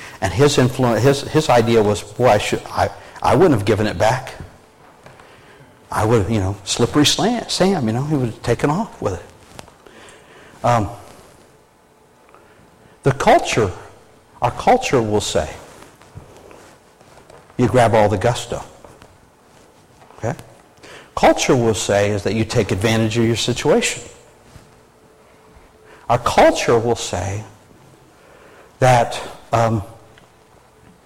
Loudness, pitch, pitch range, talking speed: -17 LUFS, 115 Hz, 105-125 Hz, 125 wpm